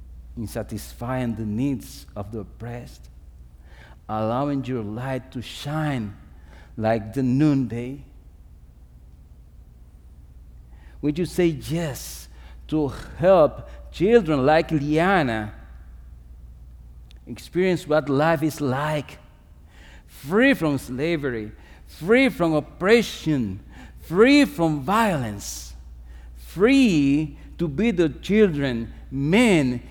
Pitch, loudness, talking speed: 115 Hz, -22 LUFS, 90 wpm